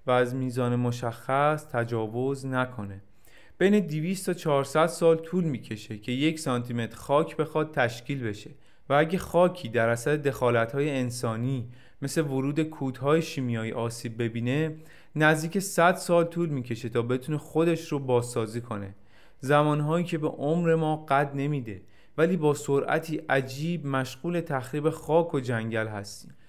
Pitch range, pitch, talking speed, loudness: 120-160 Hz, 140 Hz, 140 wpm, -27 LUFS